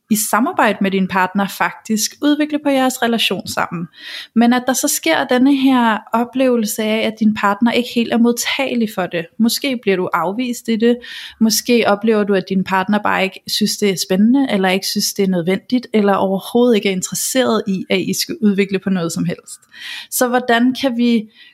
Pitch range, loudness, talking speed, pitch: 195-245 Hz, -16 LUFS, 200 wpm, 220 Hz